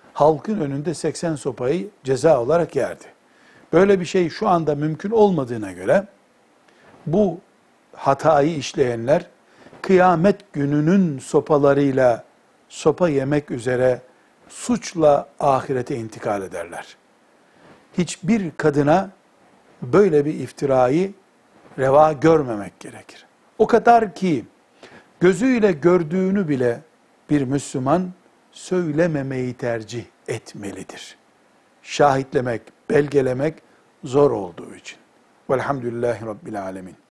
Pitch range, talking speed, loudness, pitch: 135-180 Hz, 90 wpm, -20 LUFS, 155 Hz